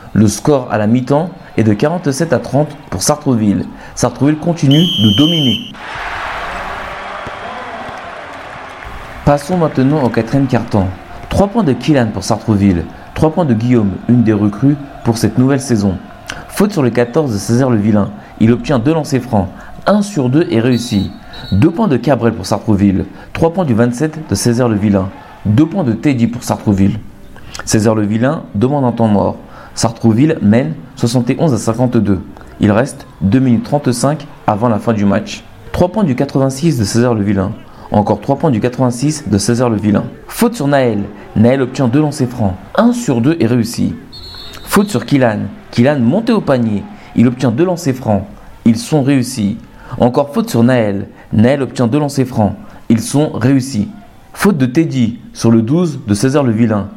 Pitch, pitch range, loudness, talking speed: 120 Hz, 110-145 Hz, -13 LUFS, 170 wpm